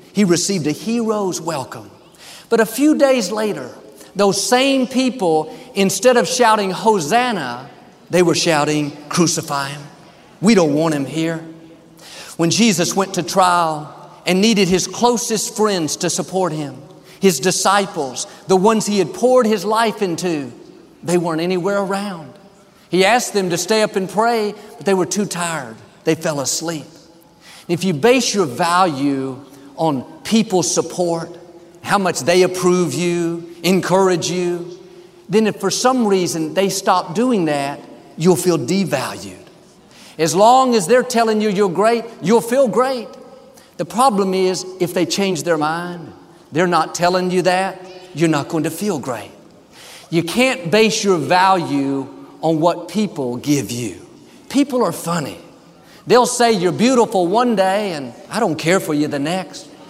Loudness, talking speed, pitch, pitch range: -17 LUFS, 155 wpm, 180 Hz, 165-210 Hz